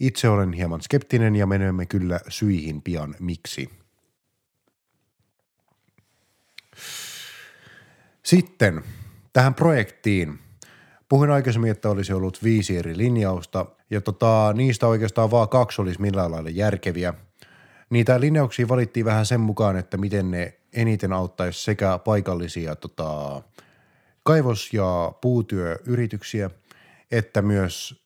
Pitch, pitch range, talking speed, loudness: 105 Hz, 90-120 Hz, 105 wpm, -23 LUFS